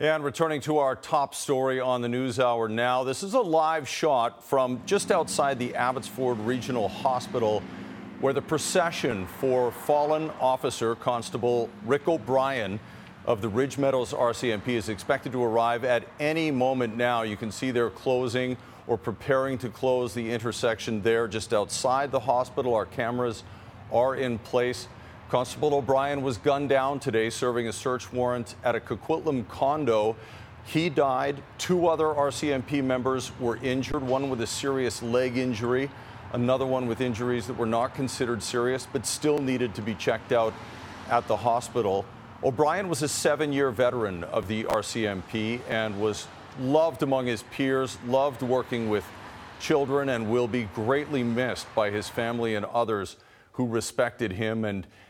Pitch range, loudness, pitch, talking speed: 115-135 Hz, -27 LUFS, 125 Hz, 160 wpm